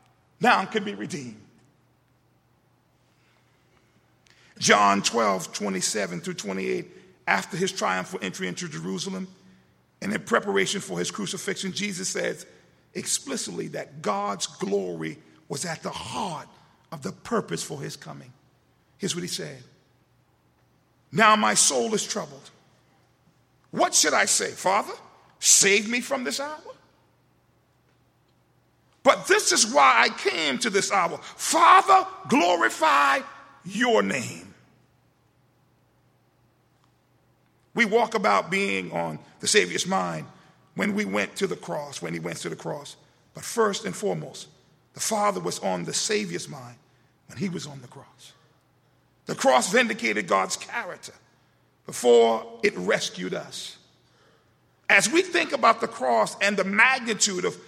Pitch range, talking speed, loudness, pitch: 130-215 Hz, 130 wpm, -23 LUFS, 190 Hz